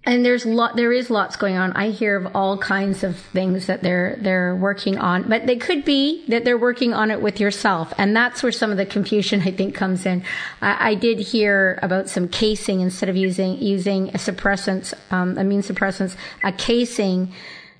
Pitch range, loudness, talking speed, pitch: 190-225 Hz, -20 LUFS, 200 wpm, 200 Hz